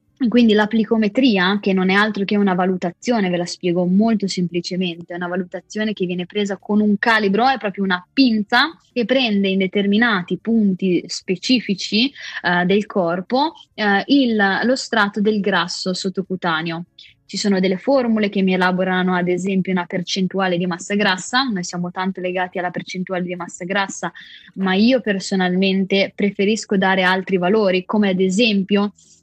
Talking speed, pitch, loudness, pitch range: 155 wpm, 195 Hz, -18 LUFS, 185-215 Hz